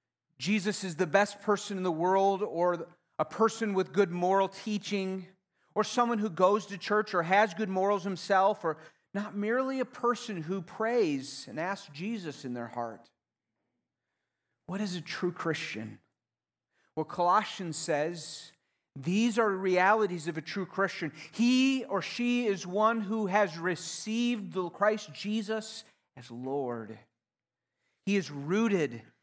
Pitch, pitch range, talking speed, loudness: 190 Hz, 160-210 Hz, 145 wpm, -30 LUFS